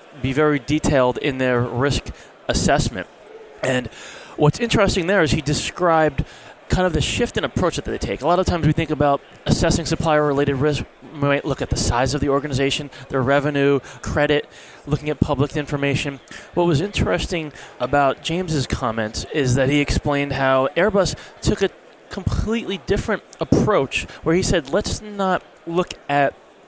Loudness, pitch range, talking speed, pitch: -20 LUFS, 135-160 Hz, 165 wpm, 145 Hz